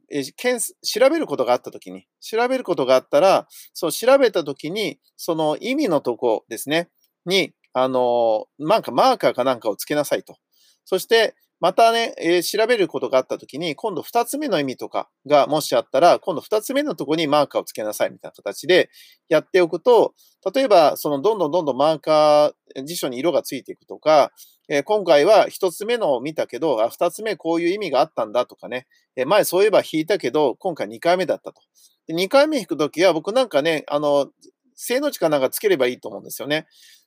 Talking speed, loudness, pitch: 395 characters per minute, -20 LUFS, 200 Hz